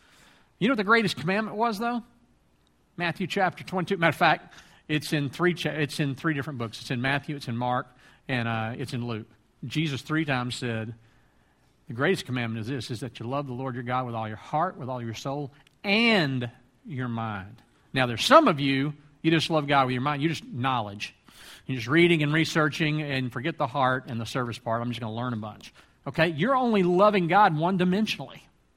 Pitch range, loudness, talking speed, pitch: 120-165 Hz, -26 LUFS, 220 wpm, 140 Hz